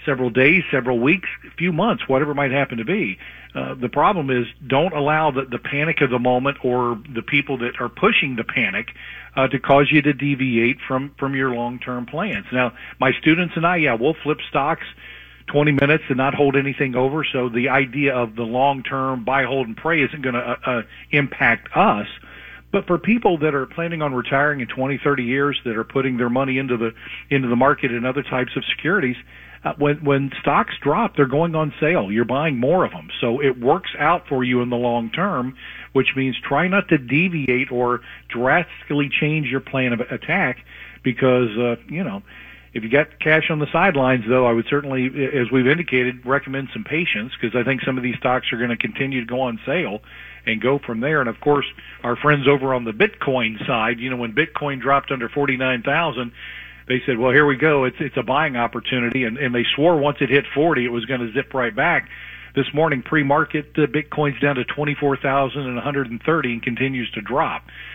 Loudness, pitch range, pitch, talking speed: -20 LUFS, 125-145 Hz, 135 Hz, 210 wpm